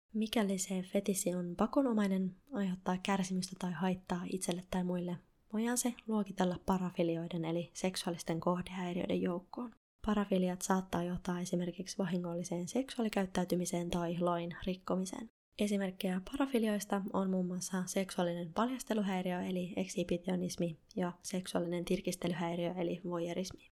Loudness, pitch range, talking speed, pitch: -37 LUFS, 175-200 Hz, 110 wpm, 185 Hz